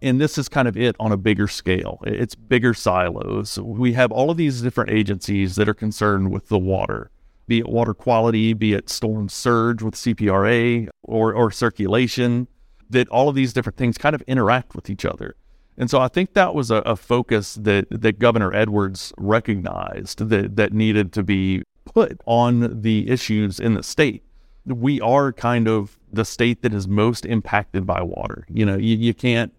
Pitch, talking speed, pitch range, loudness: 110 Hz, 190 wpm, 105-120 Hz, -20 LUFS